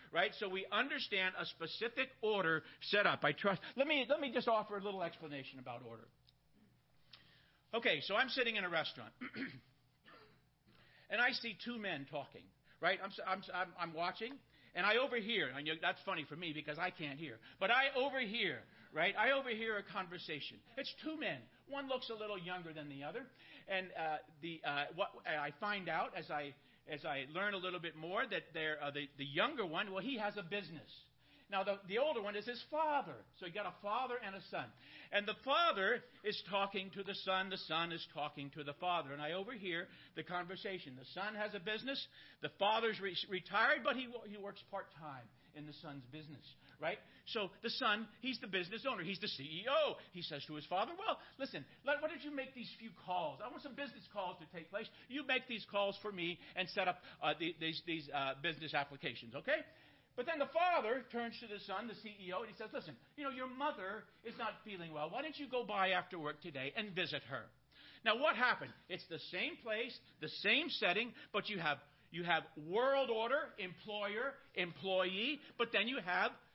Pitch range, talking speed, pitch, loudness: 160-230 Hz, 205 wpm, 195 Hz, -40 LUFS